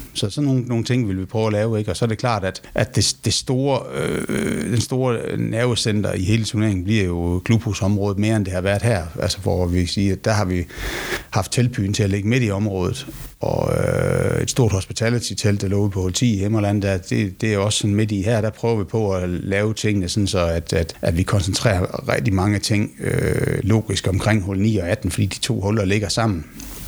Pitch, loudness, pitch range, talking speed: 105 Hz, -20 LUFS, 95-115 Hz, 235 wpm